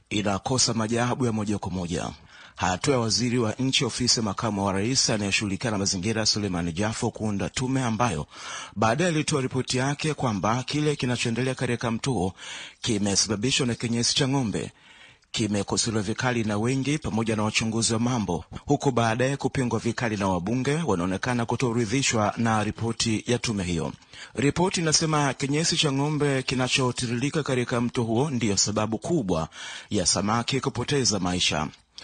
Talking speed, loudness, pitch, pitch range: 140 wpm, -25 LUFS, 120 Hz, 105-130 Hz